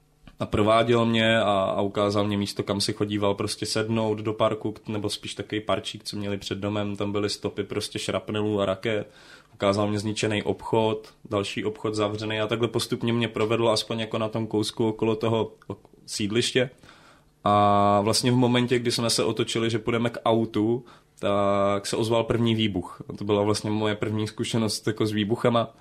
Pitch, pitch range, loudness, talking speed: 110 Hz, 105-115 Hz, -25 LUFS, 175 wpm